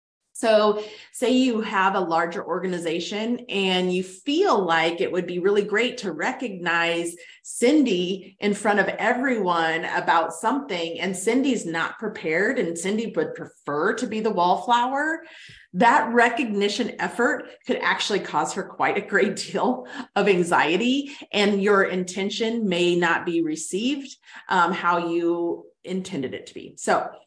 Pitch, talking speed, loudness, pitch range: 200 Hz, 145 wpm, -23 LUFS, 175-235 Hz